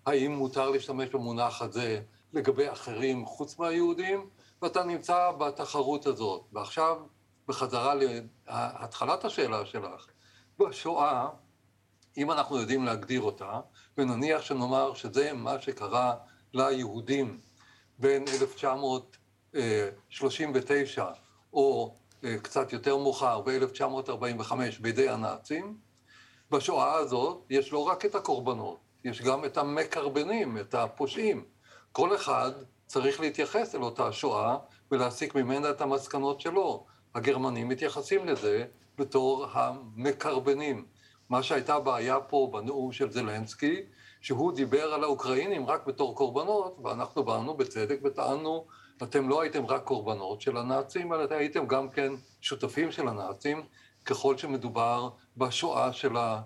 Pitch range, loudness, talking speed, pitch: 125-150 Hz, -31 LUFS, 115 wpm, 135 Hz